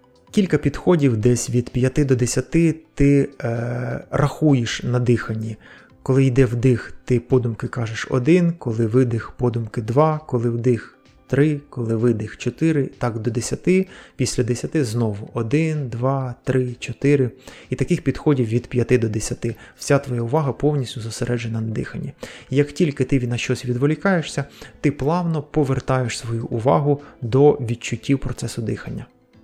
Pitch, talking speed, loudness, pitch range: 130 Hz, 140 wpm, -21 LUFS, 120-145 Hz